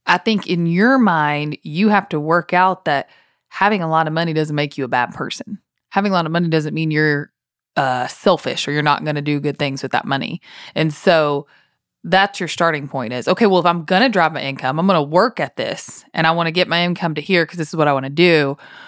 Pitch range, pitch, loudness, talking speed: 150-180 Hz, 160 Hz, -17 LUFS, 260 wpm